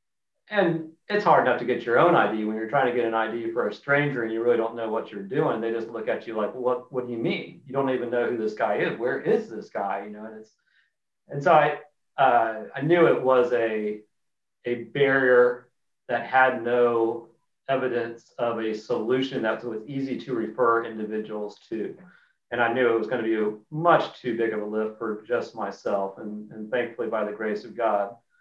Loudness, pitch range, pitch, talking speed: -25 LUFS, 110-130 Hz, 120 Hz, 220 wpm